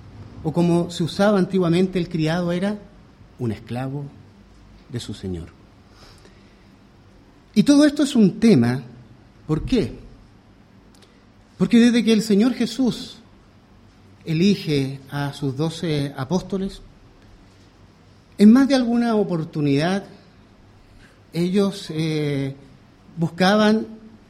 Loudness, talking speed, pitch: -20 LUFS, 100 wpm, 145 Hz